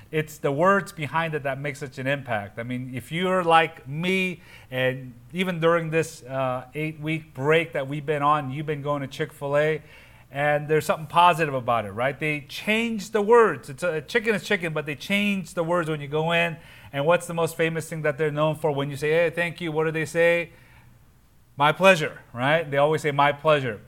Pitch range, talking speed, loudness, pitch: 140-170 Hz, 215 wpm, -24 LUFS, 155 Hz